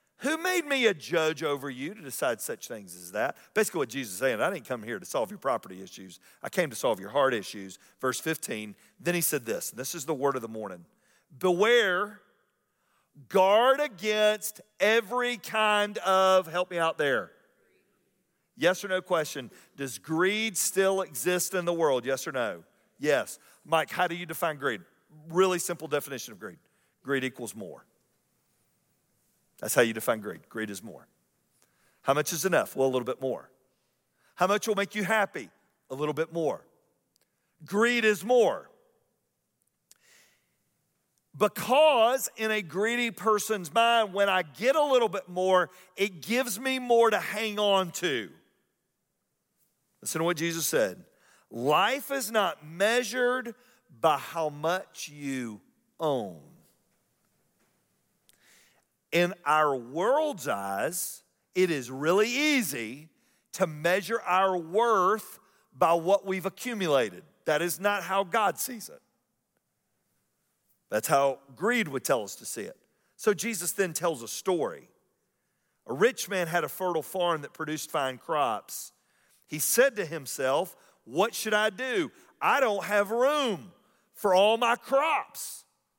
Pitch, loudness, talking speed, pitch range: 185 Hz, -28 LUFS, 150 wpm, 155-220 Hz